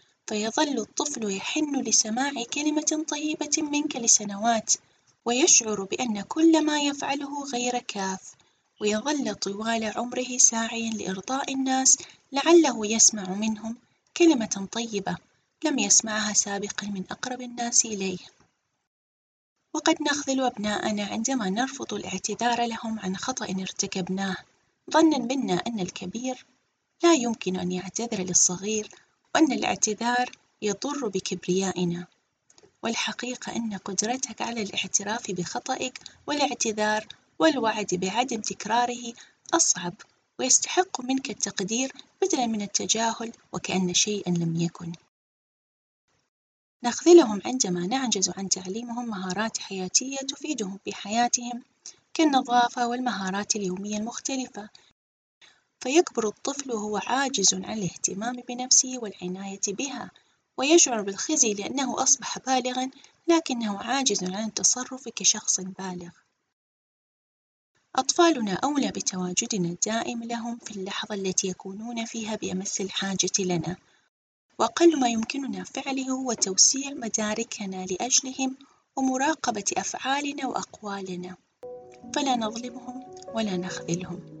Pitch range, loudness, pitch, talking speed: 195-260 Hz, -25 LUFS, 225 Hz, 100 wpm